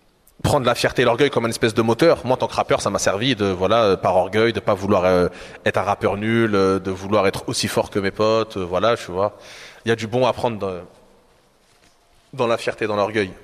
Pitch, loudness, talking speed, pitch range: 110 Hz, -20 LUFS, 235 wpm, 95-120 Hz